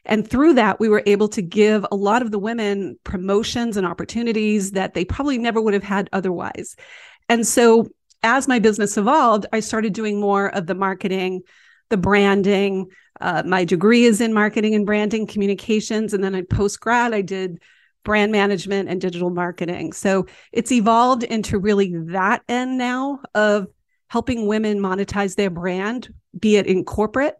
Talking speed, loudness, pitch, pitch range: 170 wpm, -19 LUFS, 210 Hz, 195-230 Hz